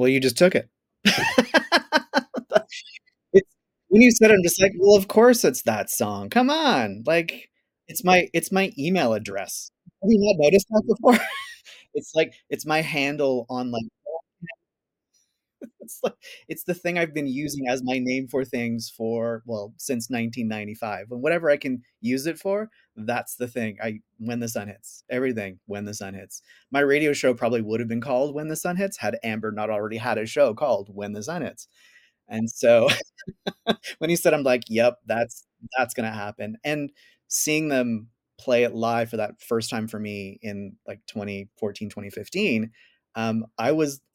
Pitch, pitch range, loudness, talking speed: 130 Hz, 115-180 Hz, -23 LUFS, 180 wpm